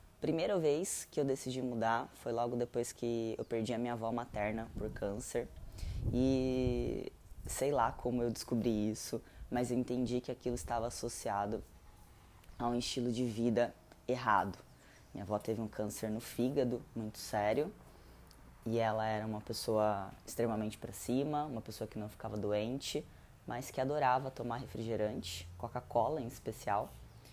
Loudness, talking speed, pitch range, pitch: -37 LUFS, 150 wpm, 105-125 Hz, 115 Hz